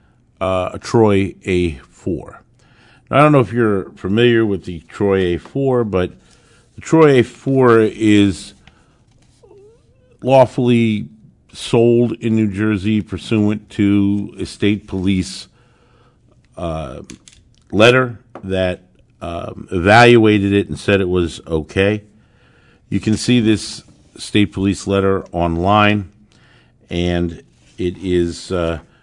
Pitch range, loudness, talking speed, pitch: 95-115 Hz, -16 LUFS, 110 wpm, 105 Hz